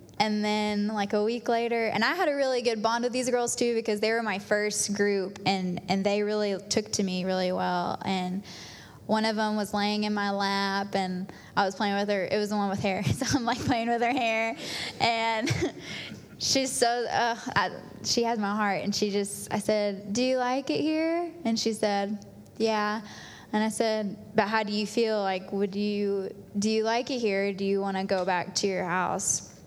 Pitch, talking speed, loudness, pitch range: 210 Hz, 220 wpm, -28 LUFS, 200-230 Hz